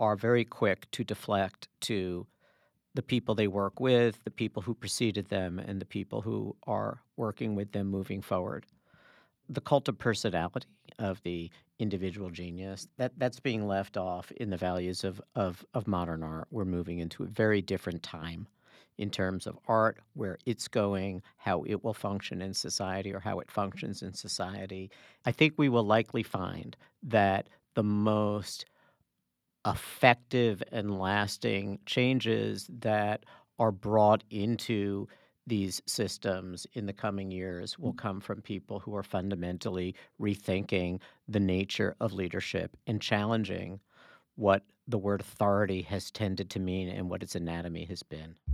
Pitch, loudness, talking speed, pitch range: 100 Hz, -32 LUFS, 155 wpm, 95-110 Hz